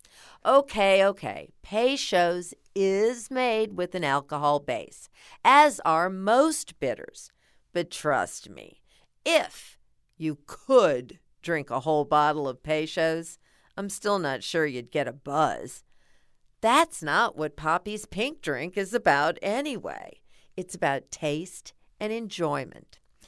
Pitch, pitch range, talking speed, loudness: 175 Hz, 150-210 Hz, 120 wpm, -26 LUFS